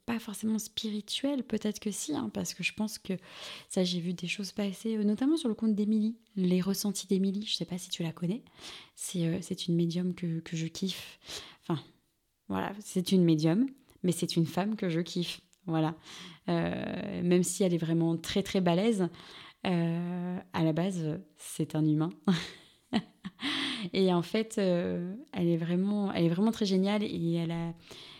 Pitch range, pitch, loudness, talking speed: 170-210 Hz, 185 Hz, -31 LUFS, 185 wpm